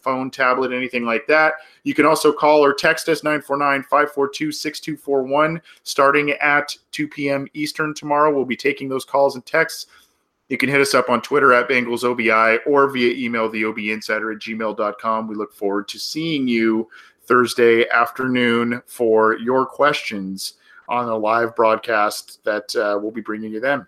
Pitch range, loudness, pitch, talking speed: 115-145 Hz, -19 LUFS, 130 Hz, 160 wpm